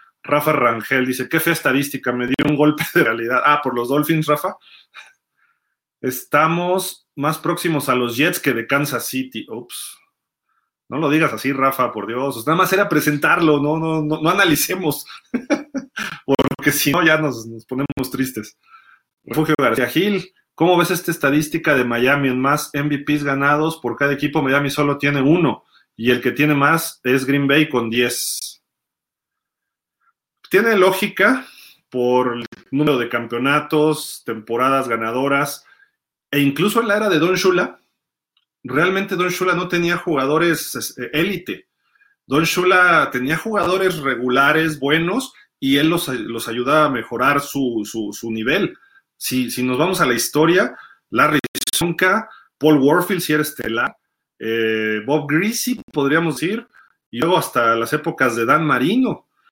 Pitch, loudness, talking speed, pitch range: 150 Hz, -18 LUFS, 150 wpm, 130-170 Hz